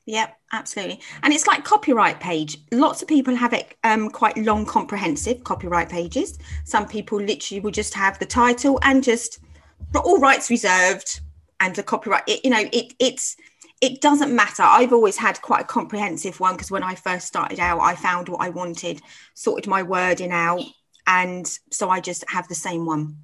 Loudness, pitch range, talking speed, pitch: -20 LUFS, 180-240 Hz, 190 wpm, 210 Hz